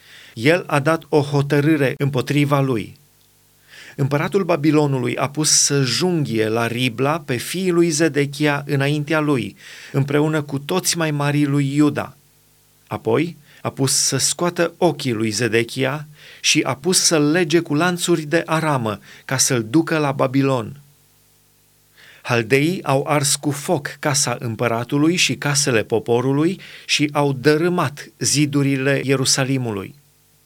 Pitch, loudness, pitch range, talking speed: 145 Hz, -18 LUFS, 135-155 Hz, 130 wpm